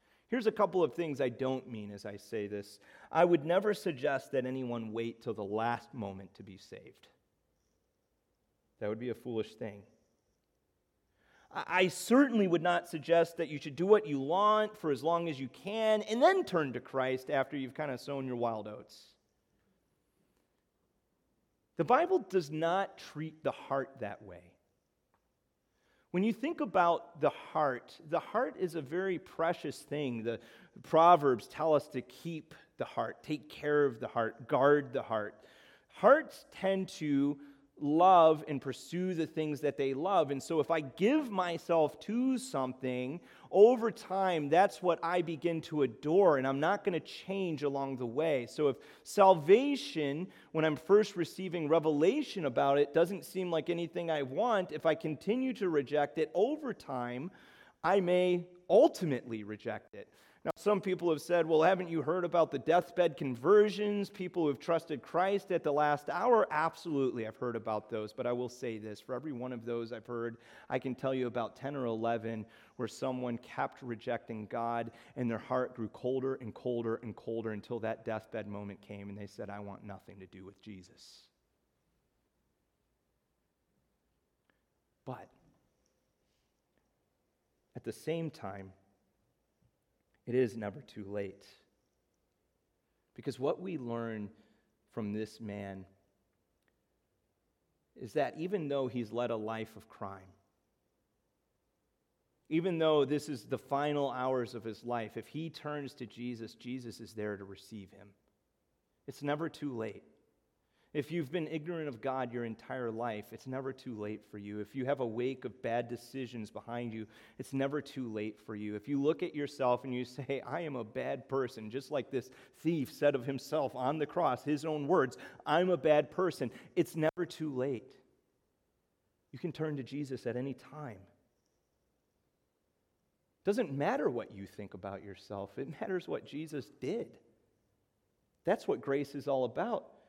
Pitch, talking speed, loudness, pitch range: 135 Hz, 165 wpm, -33 LUFS, 115-165 Hz